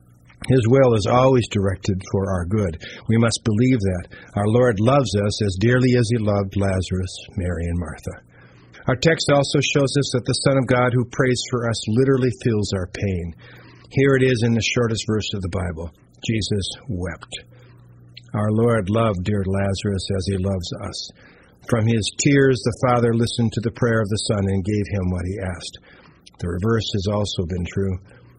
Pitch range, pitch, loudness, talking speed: 95-125 Hz, 110 Hz, -20 LUFS, 185 wpm